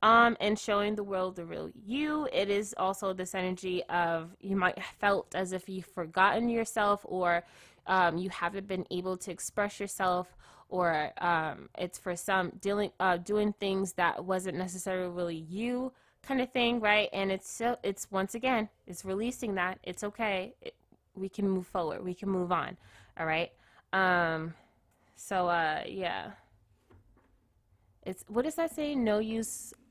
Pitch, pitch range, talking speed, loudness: 190 Hz, 180-210 Hz, 165 wpm, -32 LUFS